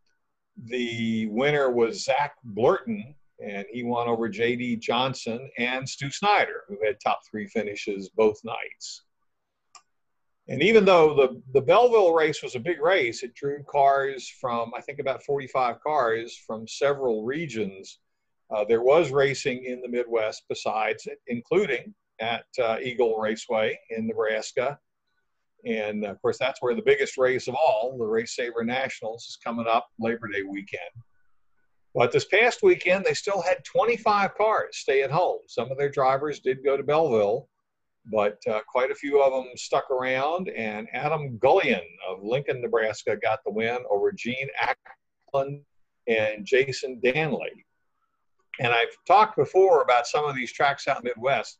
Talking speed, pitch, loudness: 160 wpm, 140 Hz, -25 LUFS